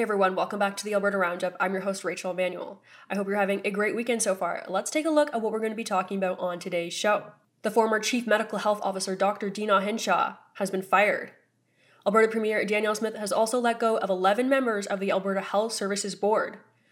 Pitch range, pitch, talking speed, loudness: 190-220 Hz, 205 Hz, 230 wpm, -26 LUFS